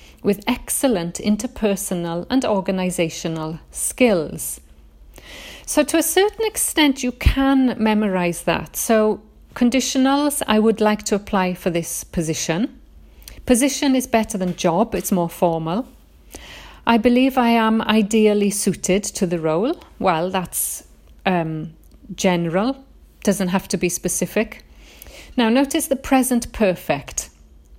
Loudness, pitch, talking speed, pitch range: -20 LUFS, 210 Hz, 120 wpm, 180-250 Hz